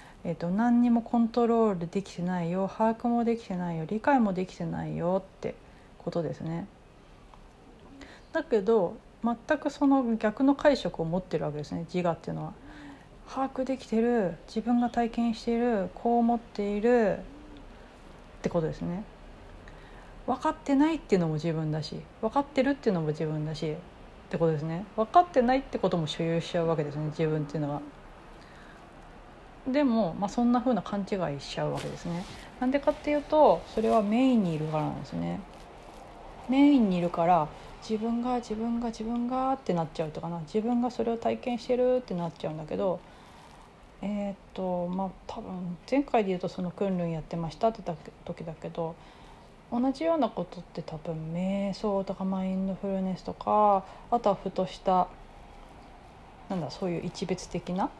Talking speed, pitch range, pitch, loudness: 365 characters per minute, 170-240 Hz, 200 Hz, -29 LUFS